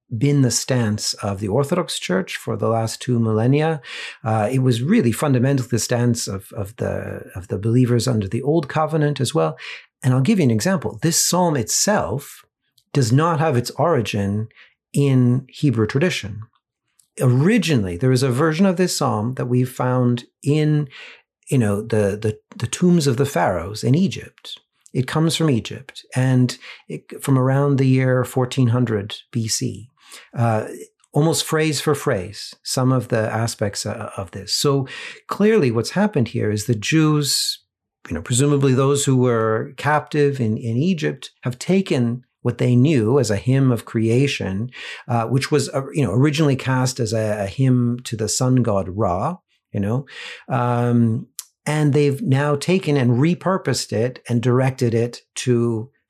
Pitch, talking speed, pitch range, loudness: 125 Hz, 165 wpm, 115-145 Hz, -20 LUFS